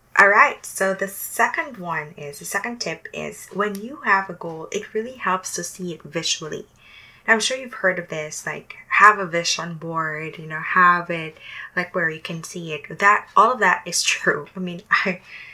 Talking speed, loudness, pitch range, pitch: 210 wpm, -21 LUFS, 165-200 Hz, 180 Hz